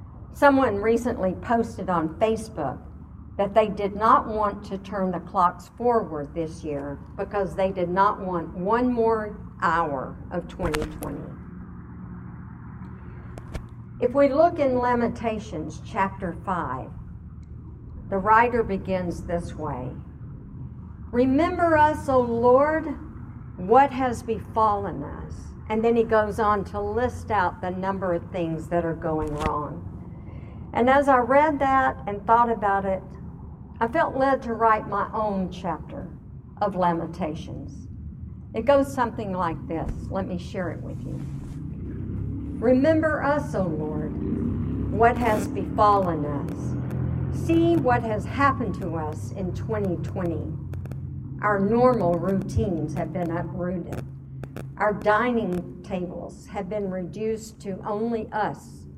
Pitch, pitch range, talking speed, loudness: 205 Hz, 175-235 Hz, 125 wpm, -24 LUFS